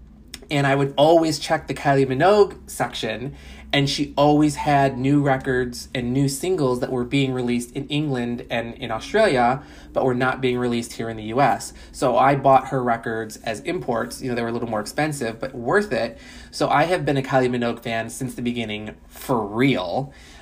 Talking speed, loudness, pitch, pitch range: 195 wpm, -22 LUFS, 130 Hz, 115-140 Hz